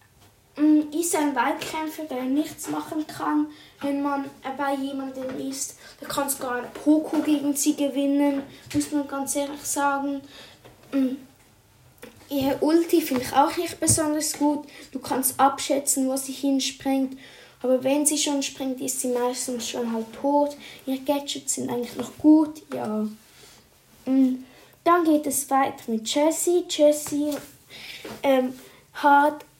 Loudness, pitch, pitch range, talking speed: -24 LUFS, 280 Hz, 265-300 Hz, 135 wpm